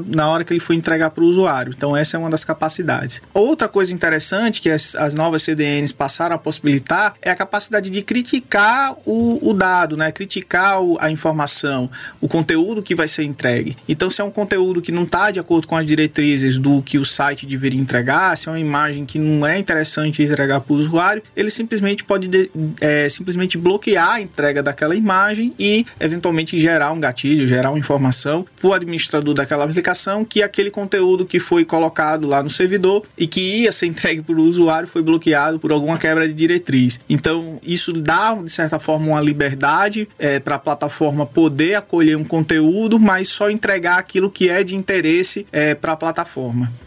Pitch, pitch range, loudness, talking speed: 165 Hz, 150-190 Hz, -17 LUFS, 195 wpm